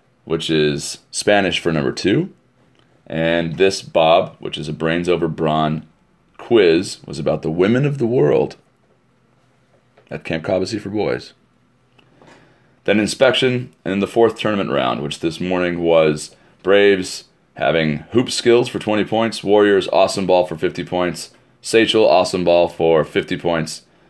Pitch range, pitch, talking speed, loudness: 80-110 Hz, 90 Hz, 145 wpm, -17 LUFS